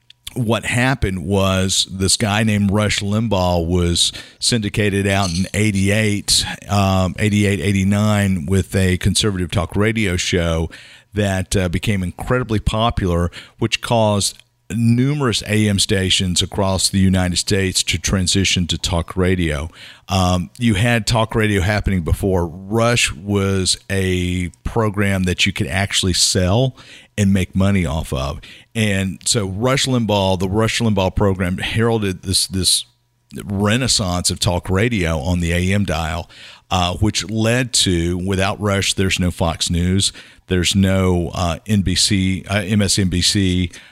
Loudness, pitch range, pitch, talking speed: -17 LUFS, 90-105 Hz, 95 Hz, 135 wpm